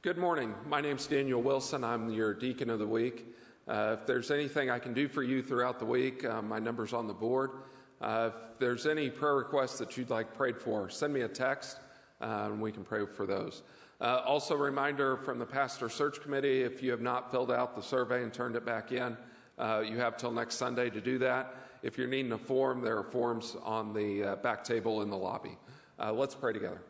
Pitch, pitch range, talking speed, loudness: 125 Hz, 115-135 Hz, 230 wpm, -34 LUFS